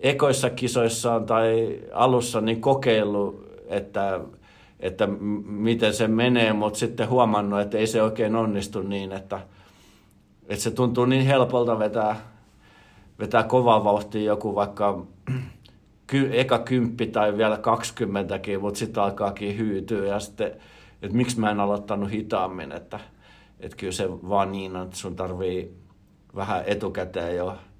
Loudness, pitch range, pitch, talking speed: -24 LUFS, 100-115 Hz, 105 Hz, 135 wpm